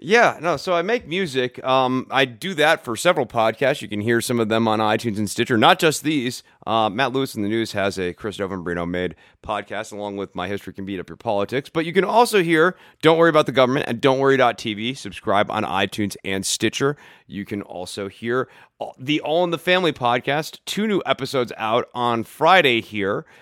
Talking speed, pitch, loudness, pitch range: 210 wpm, 120 Hz, -21 LUFS, 105-150 Hz